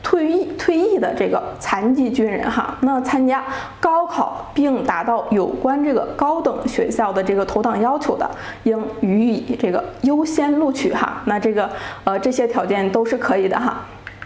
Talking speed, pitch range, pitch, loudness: 255 characters per minute, 215-285 Hz, 250 Hz, -19 LUFS